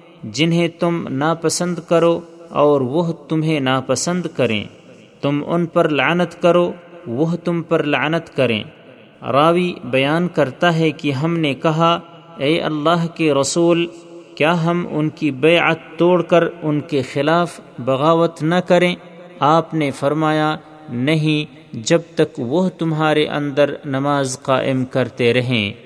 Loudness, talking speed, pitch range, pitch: -18 LUFS, 130 wpm, 145-170 Hz, 160 Hz